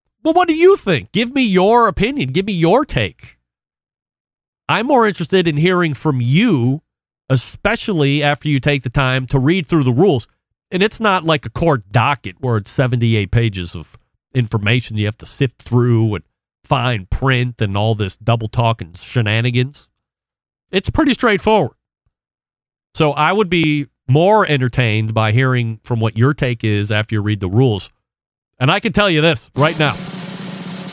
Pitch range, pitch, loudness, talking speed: 115-180 Hz, 135 Hz, -16 LUFS, 175 wpm